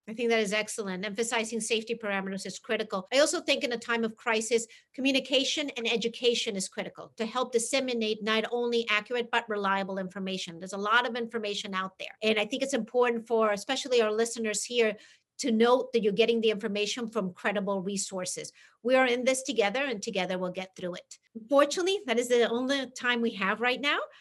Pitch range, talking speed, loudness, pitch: 210-245 Hz, 200 wpm, -29 LUFS, 230 Hz